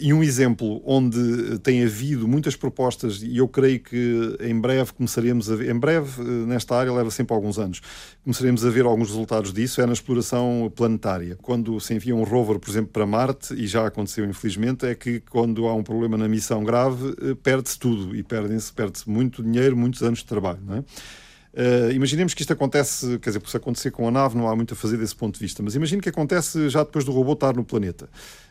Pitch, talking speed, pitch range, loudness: 120 Hz, 220 wpm, 110-130 Hz, -23 LUFS